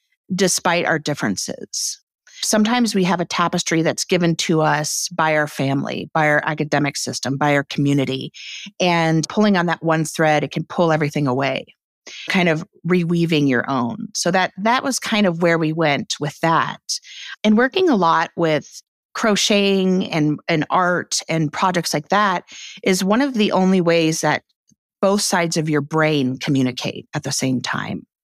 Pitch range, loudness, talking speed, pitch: 150-190 Hz, -19 LUFS, 170 wpm, 165 Hz